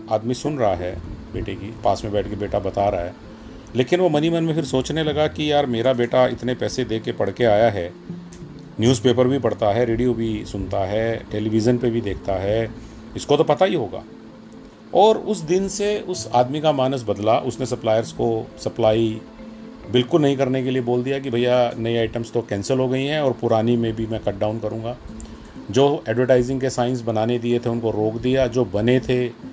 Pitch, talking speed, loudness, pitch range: 120 Hz, 205 wpm, -21 LUFS, 110-135 Hz